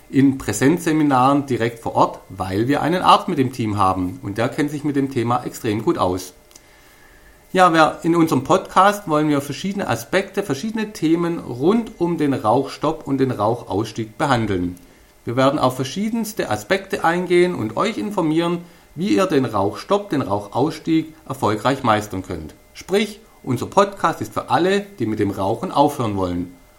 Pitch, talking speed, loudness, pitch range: 140 Hz, 160 wpm, -20 LUFS, 110-170 Hz